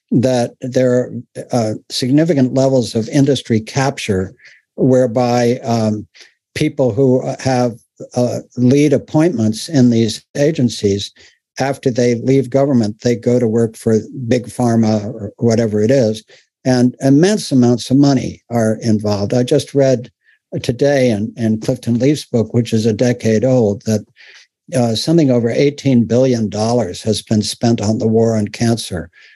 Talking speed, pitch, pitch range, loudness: 145 wpm, 120 Hz, 110-130 Hz, -15 LUFS